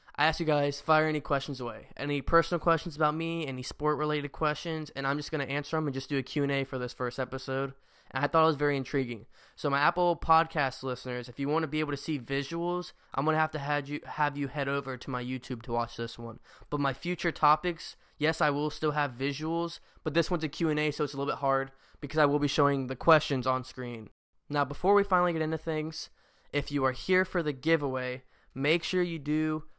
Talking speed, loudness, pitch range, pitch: 235 wpm, -30 LUFS, 135-160 Hz, 145 Hz